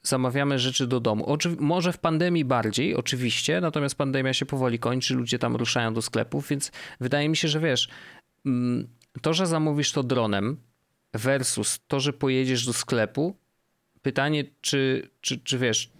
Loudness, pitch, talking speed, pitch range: -25 LUFS, 135 Hz, 160 wpm, 120-150 Hz